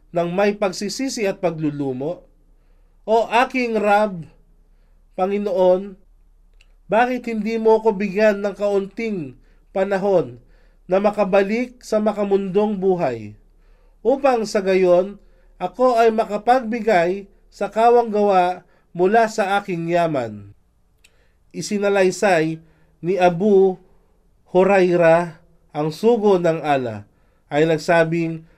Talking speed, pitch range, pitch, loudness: 95 wpm, 165-210 Hz, 190 Hz, -19 LUFS